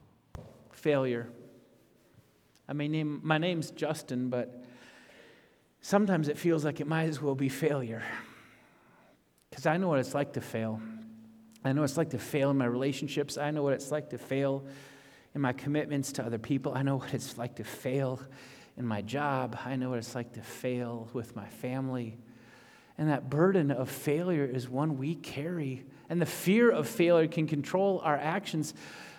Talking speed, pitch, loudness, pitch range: 180 wpm, 135 Hz, -32 LUFS, 125-150 Hz